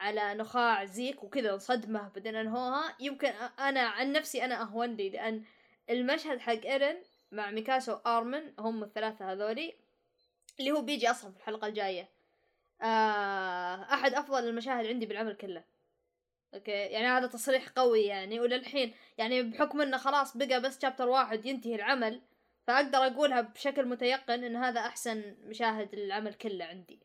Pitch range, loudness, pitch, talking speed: 215-265 Hz, -32 LUFS, 235 Hz, 145 wpm